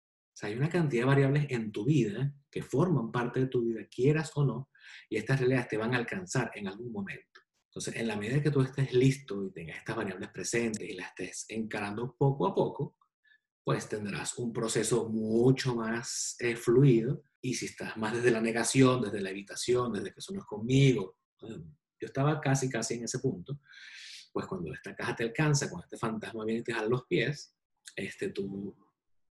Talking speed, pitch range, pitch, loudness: 195 wpm, 115-140 Hz, 125 Hz, -31 LUFS